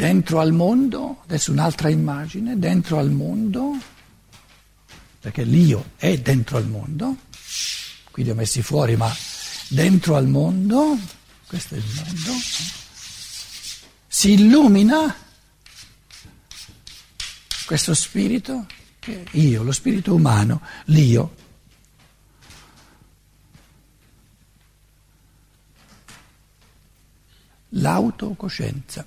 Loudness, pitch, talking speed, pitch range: -19 LUFS, 160 Hz, 80 wpm, 130-200 Hz